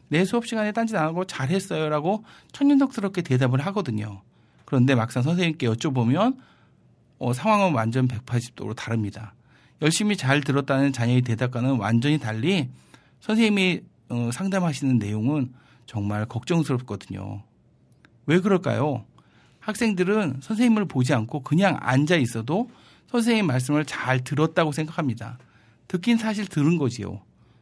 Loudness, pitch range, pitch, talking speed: -24 LUFS, 120-185 Hz, 140 Hz, 315 characters per minute